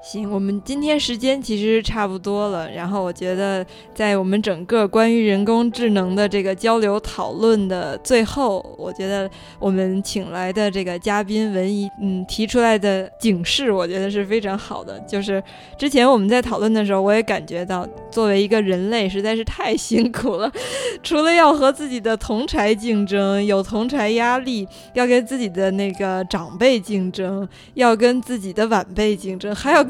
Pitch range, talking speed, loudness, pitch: 195-230 Hz, 275 characters per minute, -19 LUFS, 210 Hz